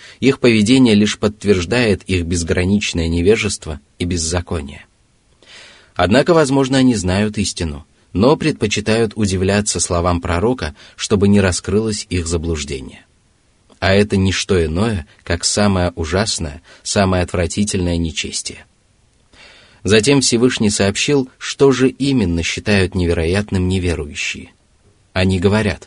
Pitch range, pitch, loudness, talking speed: 90-110 Hz, 100 Hz, -16 LUFS, 105 wpm